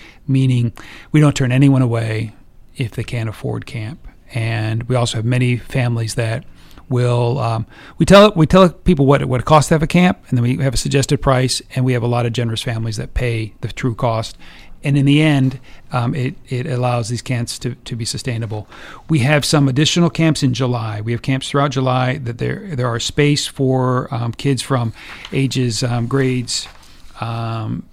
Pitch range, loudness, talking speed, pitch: 120-135 Hz, -17 LUFS, 200 wpm, 125 Hz